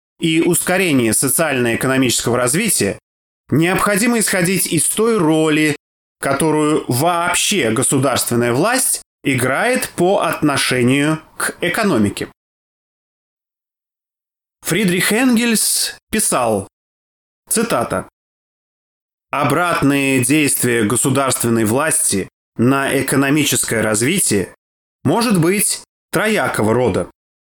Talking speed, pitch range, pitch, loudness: 70 wpm, 125-175 Hz, 145 Hz, -15 LUFS